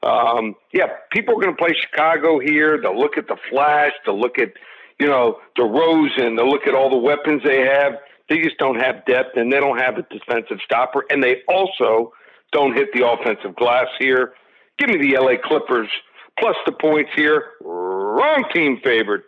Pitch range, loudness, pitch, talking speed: 125-150 Hz, -18 LUFS, 140 Hz, 195 wpm